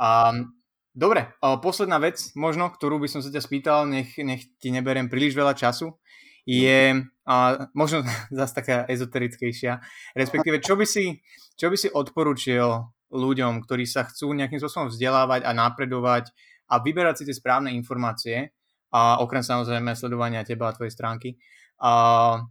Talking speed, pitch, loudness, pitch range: 150 wpm, 130 Hz, -24 LUFS, 120-145 Hz